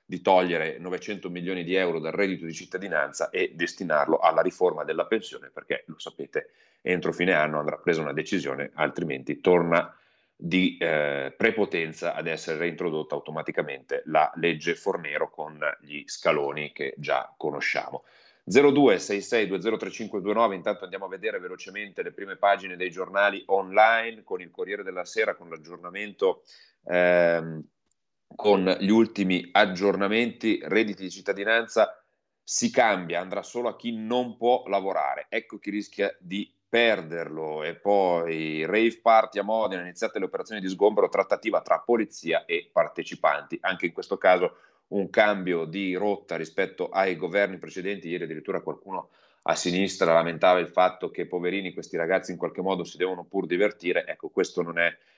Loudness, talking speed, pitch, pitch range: -26 LUFS, 150 wpm, 100 Hz, 90-115 Hz